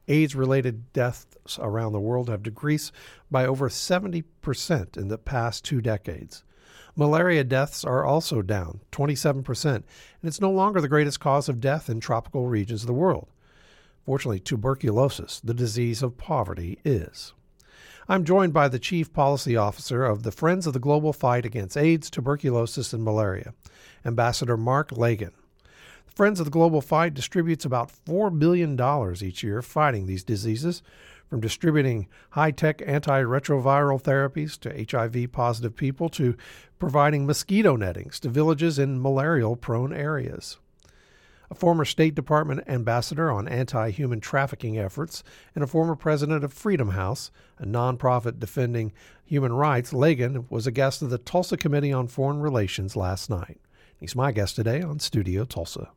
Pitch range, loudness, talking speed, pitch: 115-150 Hz, -25 LUFS, 150 wpm, 135 Hz